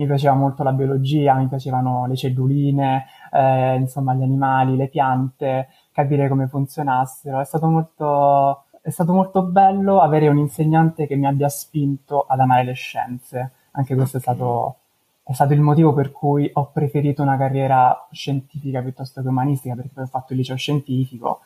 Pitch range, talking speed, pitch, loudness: 130-145 Hz, 170 wpm, 135 Hz, -19 LUFS